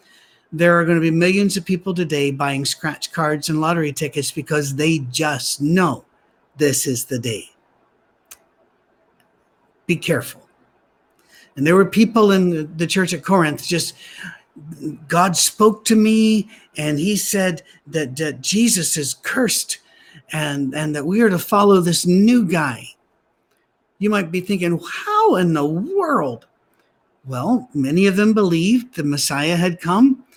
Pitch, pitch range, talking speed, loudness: 170 Hz, 150-195 Hz, 145 wpm, -18 LUFS